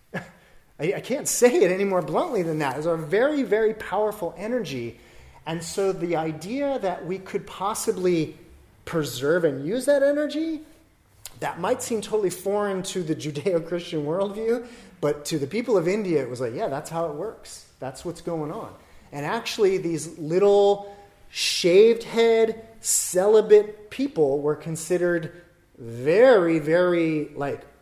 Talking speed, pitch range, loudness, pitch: 140 wpm, 160-220 Hz, -23 LUFS, 185 Hz